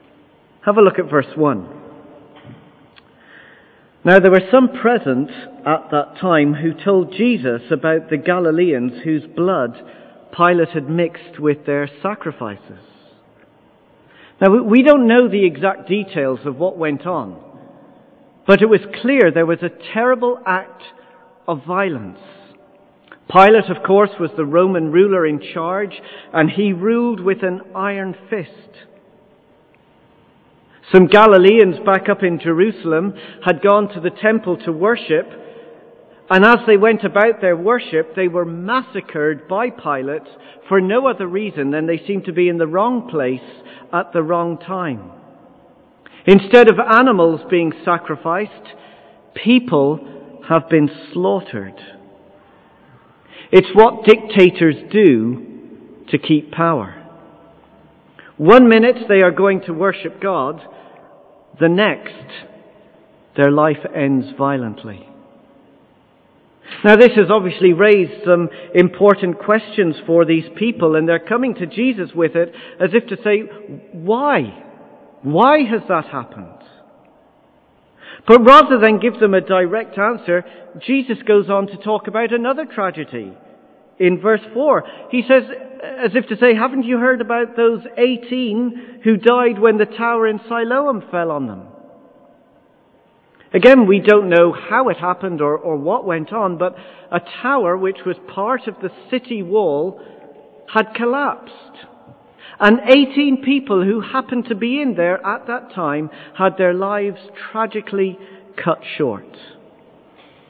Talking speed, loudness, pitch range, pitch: 135 wpm, -15 LUFS, 165-225 Hz, 190 Hz